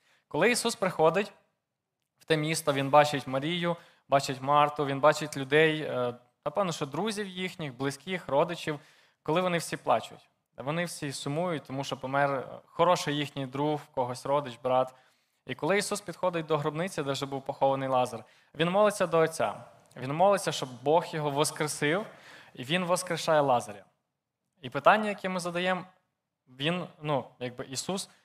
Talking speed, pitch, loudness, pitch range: 150 wpm, 155 Hz, -29 LUFS, 140-175 Hz